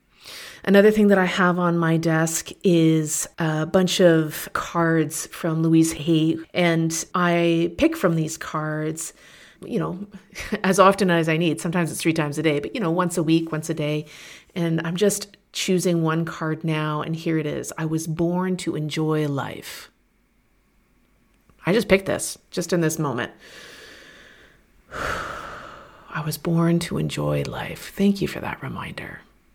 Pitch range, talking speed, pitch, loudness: 155-180 Hz, 160 wpm, 165 Hz, -22 LUFS